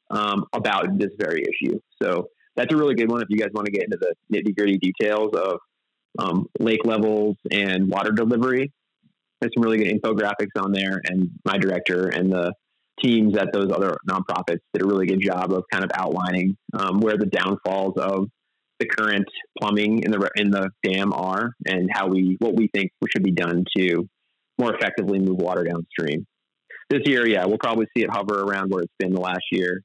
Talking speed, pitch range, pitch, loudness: 200 wpm, 95-110 Hz, 100 Hz, -22 LUFS